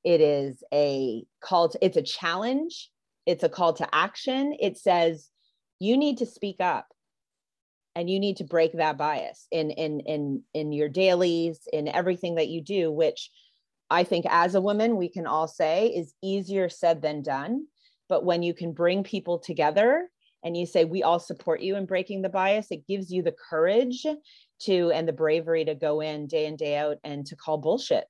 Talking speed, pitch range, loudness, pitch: 195 wpm, 155-200 Hz, -26 LUFS, 175 Hz